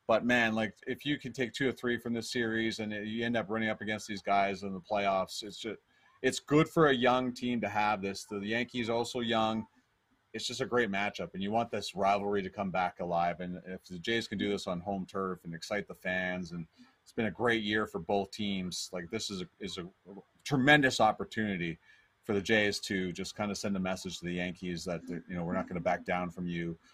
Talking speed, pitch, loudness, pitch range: 245 wpm, 105 Hz, -33 LUFS, 95-115 Hz